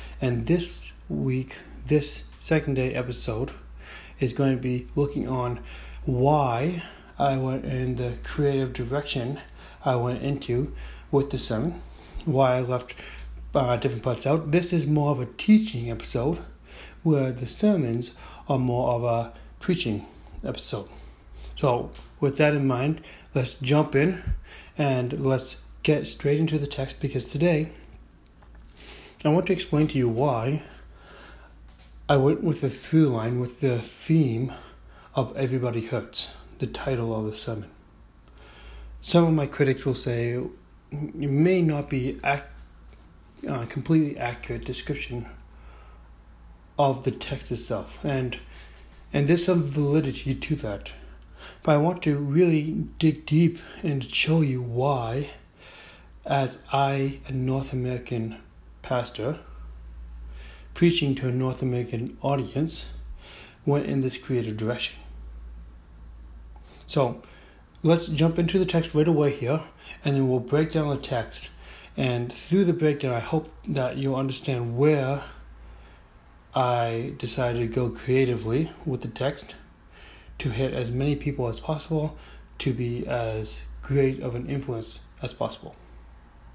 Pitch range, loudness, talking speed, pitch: 95-145 Hz, -26 LUFS, 135 wpm, 130 Hz